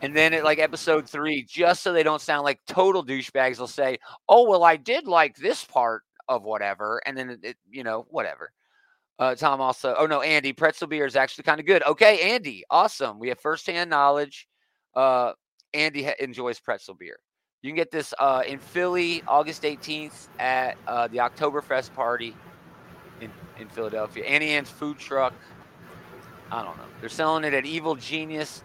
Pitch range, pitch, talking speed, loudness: 130-155 Hz, 145 Hz, 185 wpm, -24 LUFS